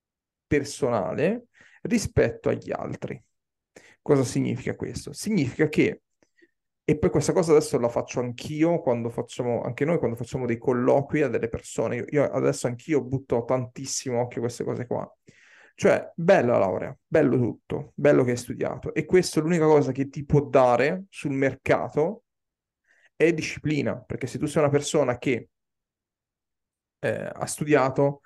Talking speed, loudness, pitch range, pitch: 150 wpm, -25 LUFS, 125-155 Hz, 140 Hz